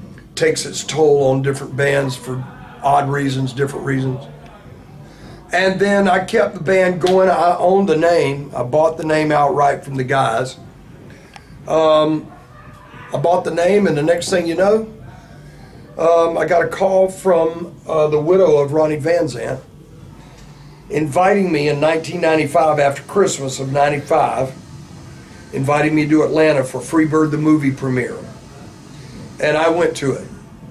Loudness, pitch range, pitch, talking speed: -16 LUFS, 140-170 Hz, 155 Hz, 150 wpm